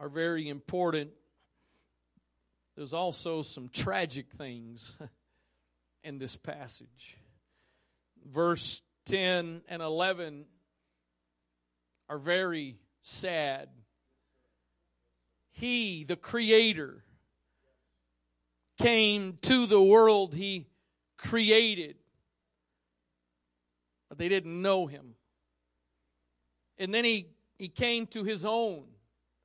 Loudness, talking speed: -28 LUFS, 80 wpm